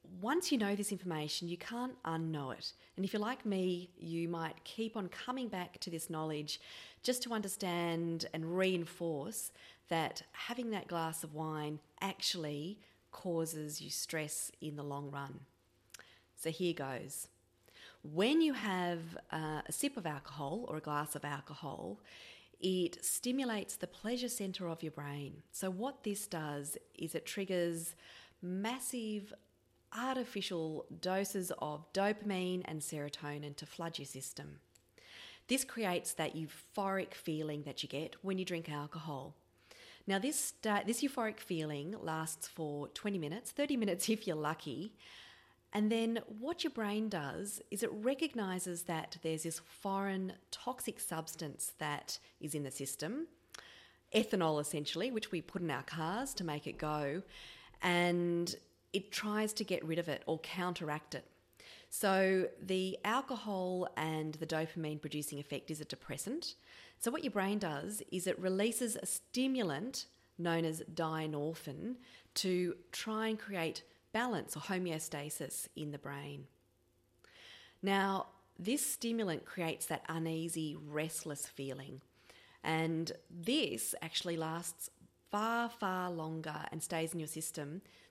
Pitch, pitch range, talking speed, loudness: 175 Hz, 155-210 Hz, 140 wpm, -39 LUFS